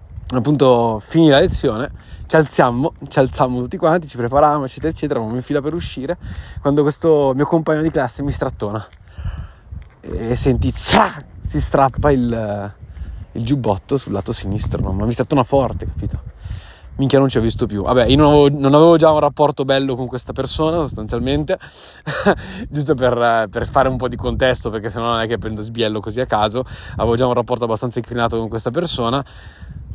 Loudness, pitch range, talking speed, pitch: -17 LUFS, 110-140 Hz, 185 wpm, 125 Hz